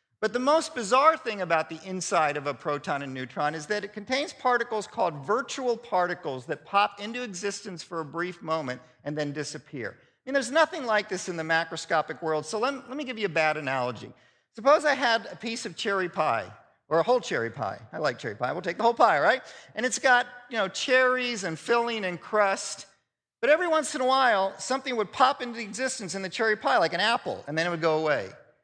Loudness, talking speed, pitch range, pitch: -27 LUFS, 230 wpm, 160-245 Hz, 200 Hz